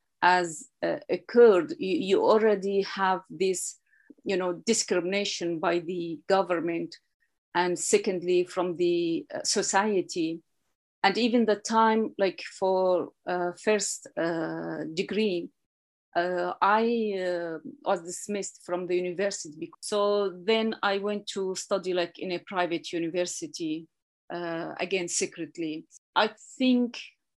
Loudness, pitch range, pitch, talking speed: -27 LUFS, 175-210 Hz, 190 Hz, 115 wpm